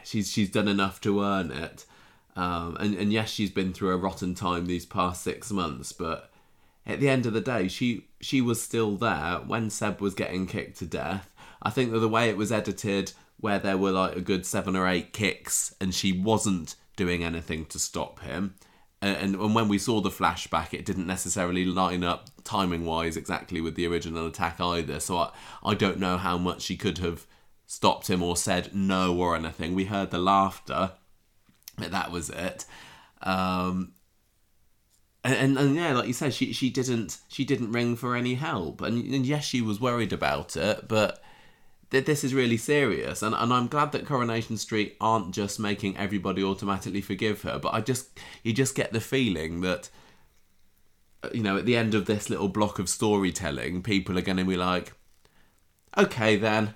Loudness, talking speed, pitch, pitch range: -28 LUFS, 195 wpm, 100 Hz, 90-110 Hz